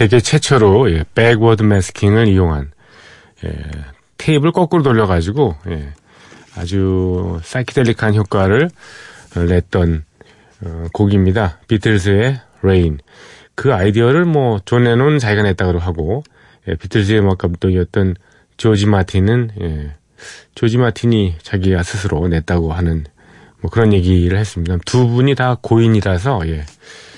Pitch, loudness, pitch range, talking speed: 100 Hz, -15 LUFS, 90-115 Hz, 270 characters per minute